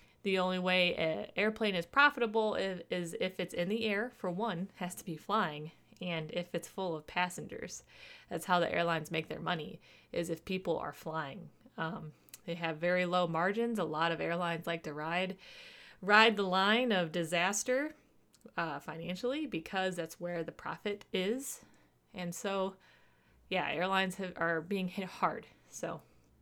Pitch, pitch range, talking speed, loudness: 180 Hz, 170-205 Hz, 165 wpm, -34 LUFS